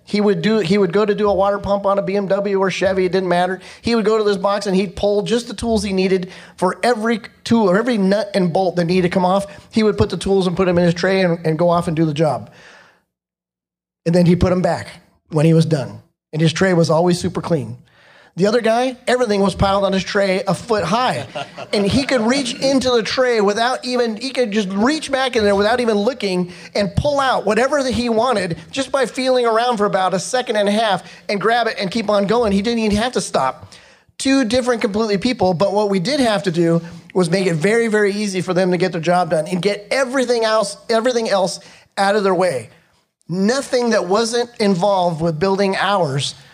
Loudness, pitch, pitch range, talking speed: -17 LUFS, 200 Hz, 185-230 Hz, 240 wpm